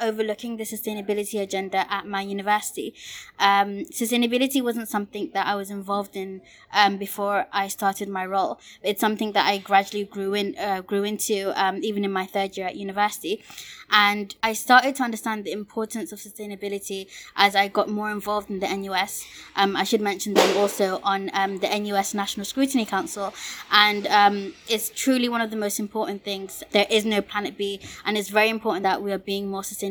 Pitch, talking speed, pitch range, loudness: 205 Hz, 190 wpm, 195-215 Hz, -24 LUFS